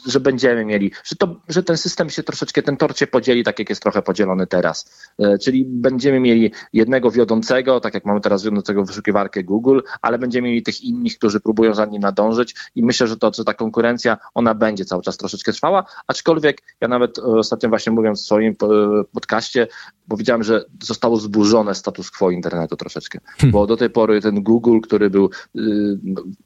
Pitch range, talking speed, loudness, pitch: 105-130 Hz, 180 wpm, -18 LUFS, 110 Hz